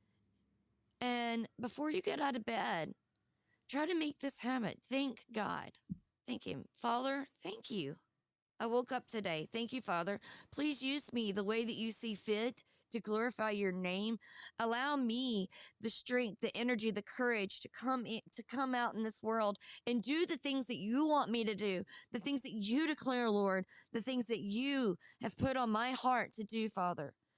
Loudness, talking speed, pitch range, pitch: -39 LUFS, 185 wpm, 210-255 Hz, 230 Hz